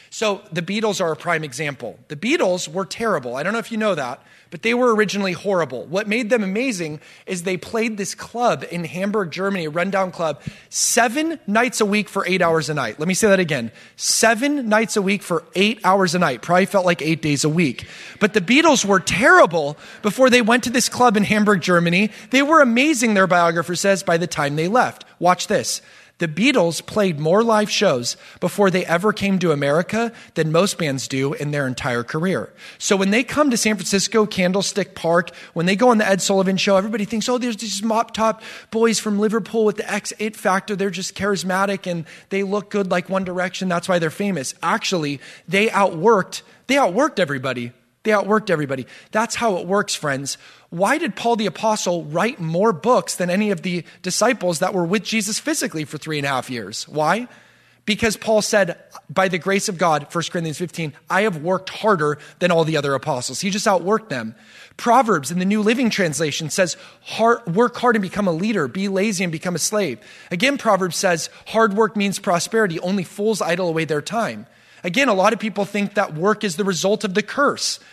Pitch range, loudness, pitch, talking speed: 170-220 Hz, -19 LUFS, 195 Hz, 205 wpm